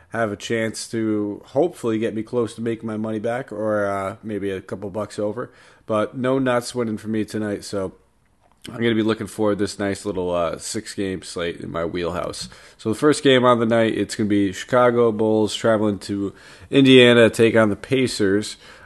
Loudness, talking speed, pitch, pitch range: -21 LUFS, 195 wpm, 110 Hz, 100-115 Hz